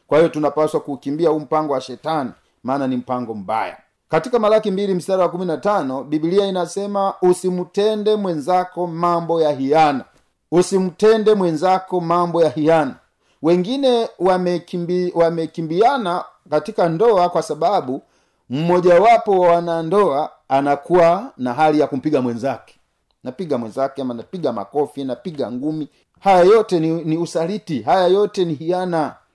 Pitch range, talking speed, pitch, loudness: 150-185 Hz, 135 wpm, 170 Hz, -18 LUFS